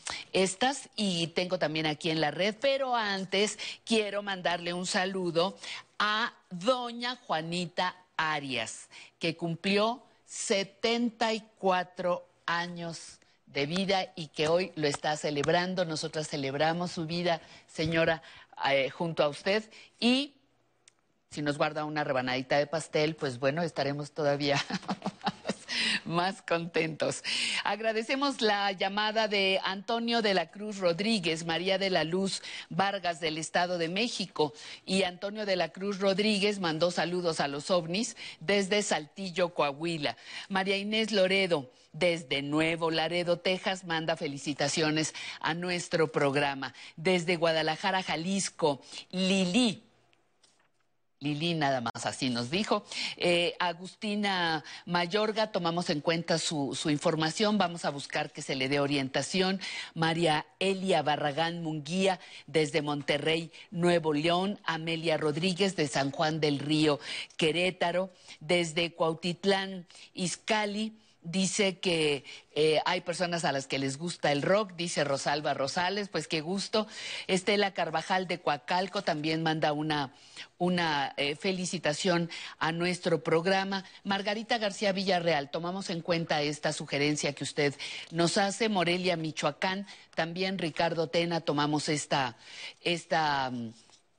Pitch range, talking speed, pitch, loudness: 155-195 Hz, 125 wpm, 175 Hz, -30 LUFS